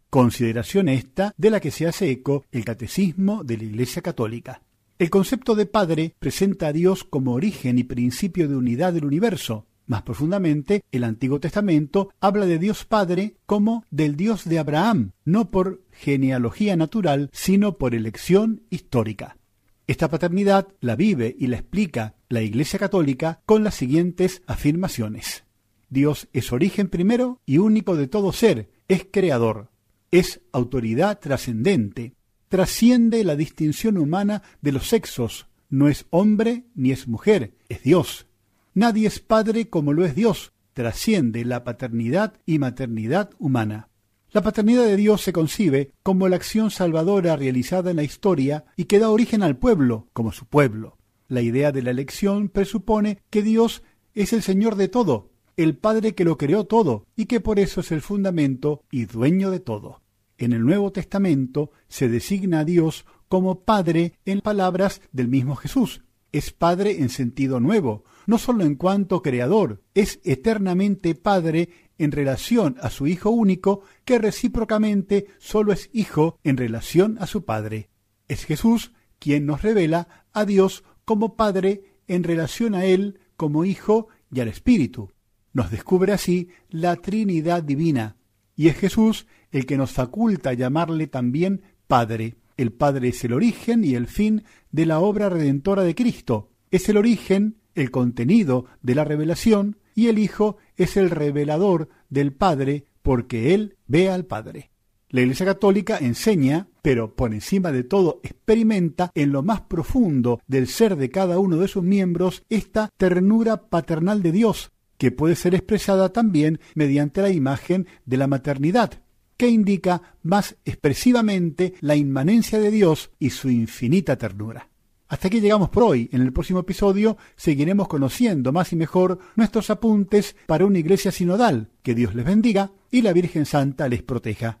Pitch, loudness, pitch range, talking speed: 170 Hz, -21 LUFS, 130-200 Hz, 155 wpm